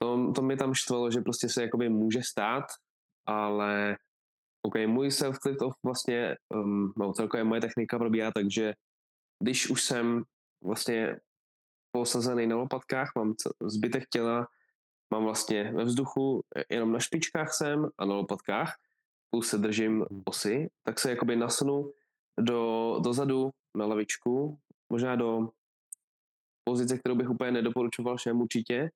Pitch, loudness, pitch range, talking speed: 120 Hz, -30 LUFS, 110-125 Hz, 135 wpm